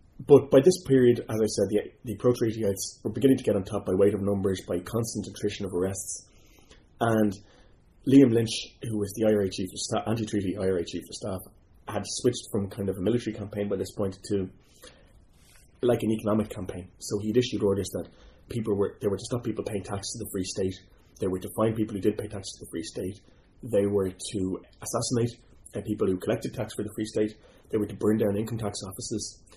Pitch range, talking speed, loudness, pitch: 100-115 Hz, 215 wpm, -28 LUFS, 105 Hz